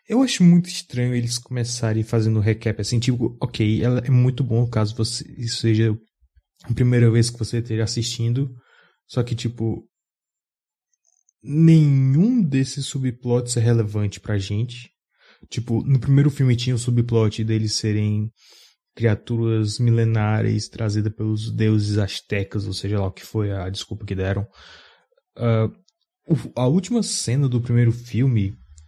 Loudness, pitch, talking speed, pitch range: -21 LUFS, 115 Hz, 140 wpm, 110-130 Hz